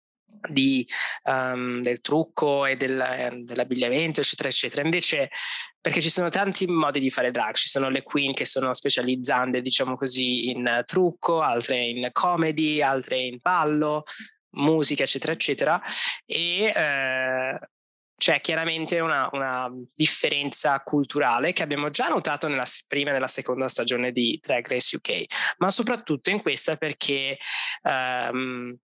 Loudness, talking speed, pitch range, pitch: -23 LUFS, 135 wpm, 125-160 Hz, 140 Hz